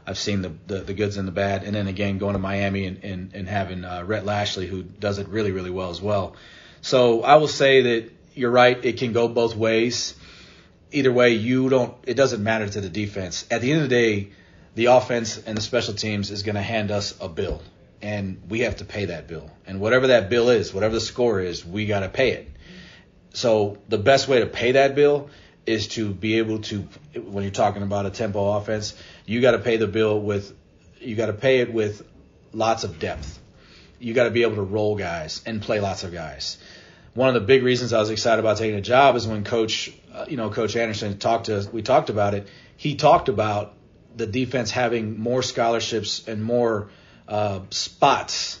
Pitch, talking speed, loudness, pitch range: 110 Hz, 220 wpm, -22 LUFS, 100-115 Hz